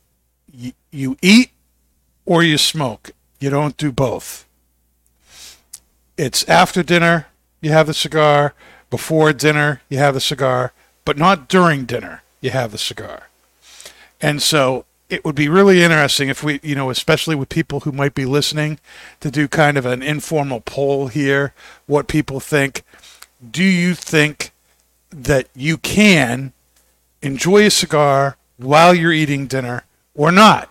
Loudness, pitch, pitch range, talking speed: -15 LUFS, 145 Hz, 125-155 Hz, 145 wpm